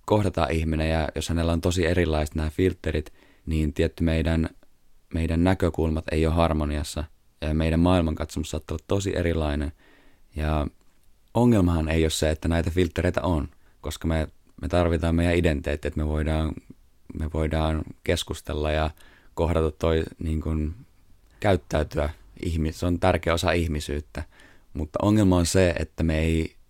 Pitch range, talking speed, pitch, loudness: 75-85 Hz, 145 wpm, 80 Hz, -25 LUFS